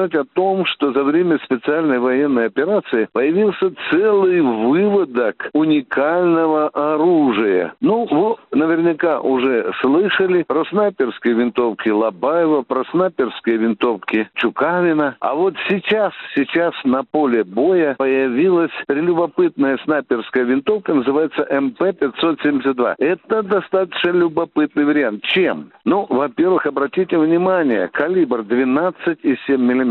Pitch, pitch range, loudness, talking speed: 155 Hz, 135-185 Hz, -17 LUFS, 100 wpm